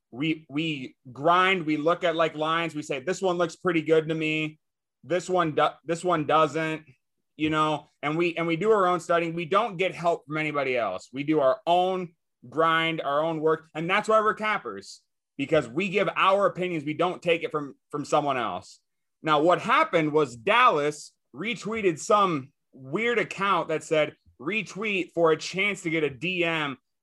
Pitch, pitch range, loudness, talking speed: 165 Hz, 155-180 Hz, -25 LUFS, 190 wpm